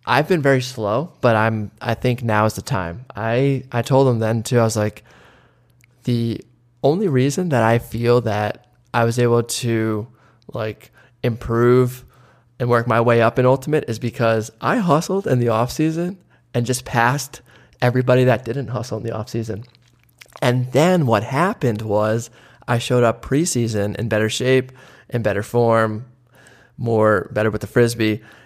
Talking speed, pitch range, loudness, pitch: 165 wpm, 115-130 Hz, -19 LUFS, 120 Hz